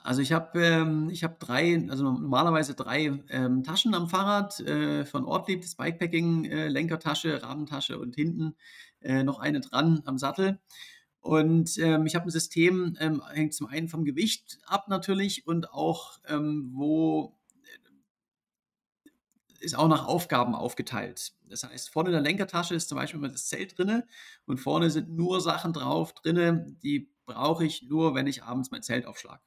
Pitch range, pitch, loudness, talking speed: 150-175 Hz, 160 Hz, -28 LUFS, 170 wpm